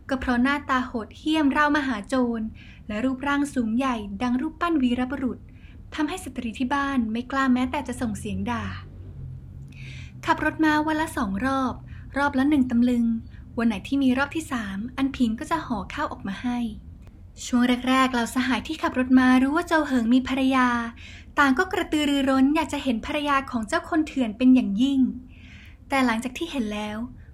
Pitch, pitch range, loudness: 260 Hz, 240-285 Hz, -24 LUFS